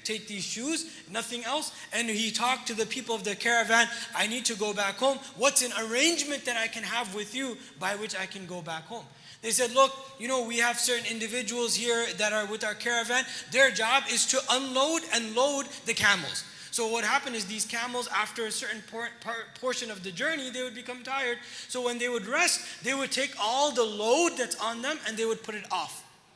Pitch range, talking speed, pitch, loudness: 220-260 Hz, 225 wpm, 235 Hz, -28 LUFS